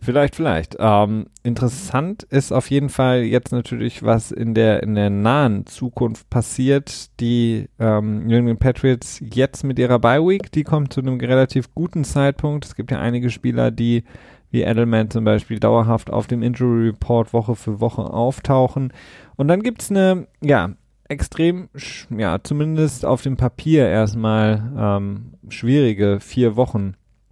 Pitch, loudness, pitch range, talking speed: 120 Hz, -19 LUFS, 110-135 Hz, 155 wpm